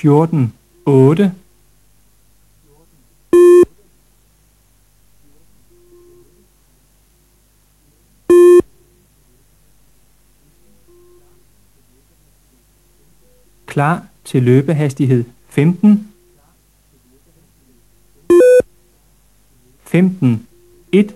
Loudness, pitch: -12 LUFS, 165 Hz